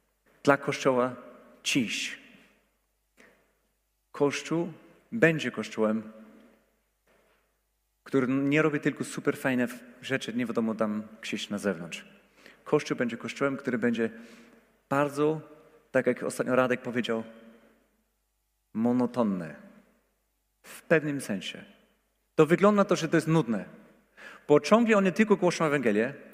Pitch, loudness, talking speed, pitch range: 140 Hz, -28 LUFS, 105 wpm, 120-160 Hz